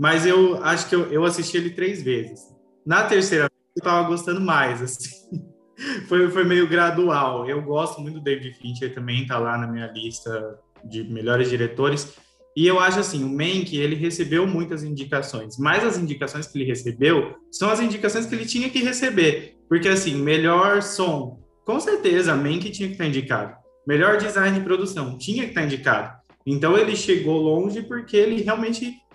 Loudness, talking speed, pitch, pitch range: -22 LUFS, 180 wpm, 170 Hz, 140-195 Hz